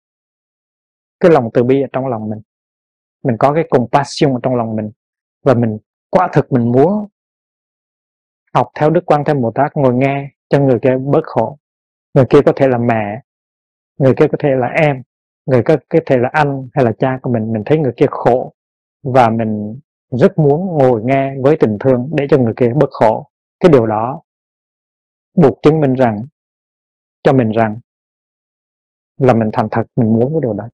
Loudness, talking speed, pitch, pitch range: -14 LUFS, 190 wpm, 130 Hz, 115-145 Hz